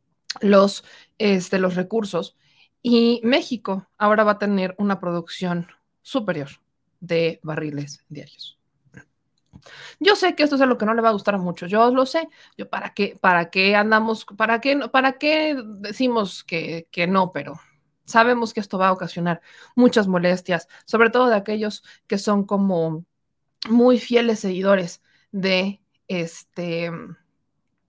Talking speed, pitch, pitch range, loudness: 145 wpm, 195 Hz, 170-225 Hz, -21 LUFS